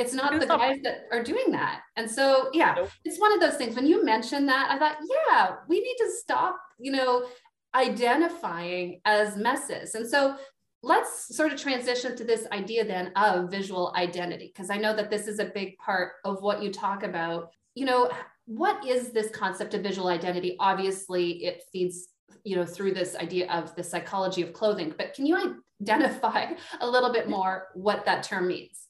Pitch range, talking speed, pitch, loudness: 185-270 Hz, 195 wpm, 215 Hz, -27 LUFS